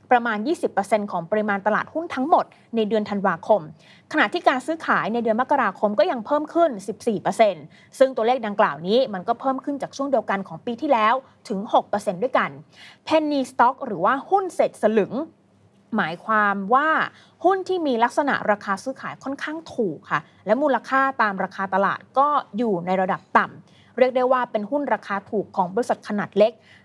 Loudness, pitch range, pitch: -22 LUFS, 200-275 Hz, 230 Hz